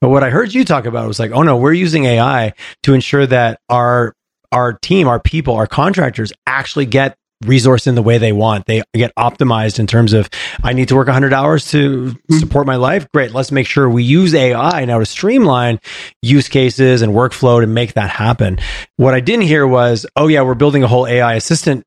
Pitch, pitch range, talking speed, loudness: 130 Hz, 120-145 Hz, 215 wpm, -12 LUFS